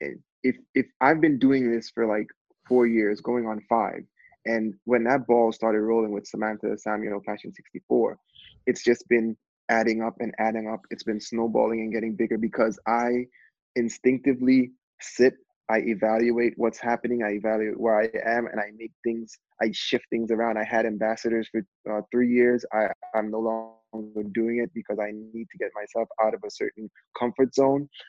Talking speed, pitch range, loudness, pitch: 180 wpm, 110-120 Hz, -26 LUFS, 115 Hz